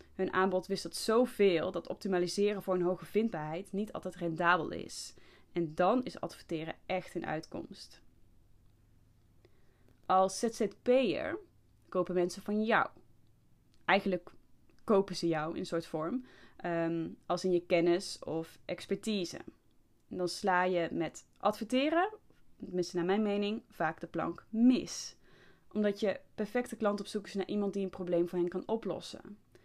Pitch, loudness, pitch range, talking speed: 185 Hz, -34 LUFS, 170-205 Hz, 145 wpm